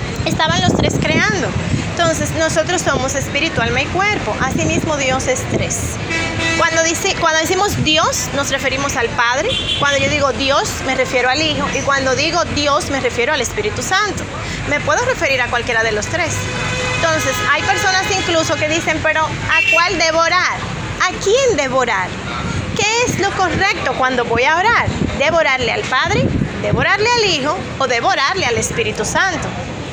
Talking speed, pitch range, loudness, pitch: 165 wpm, 270-385 Hz, -15 LUFS, 325 Hz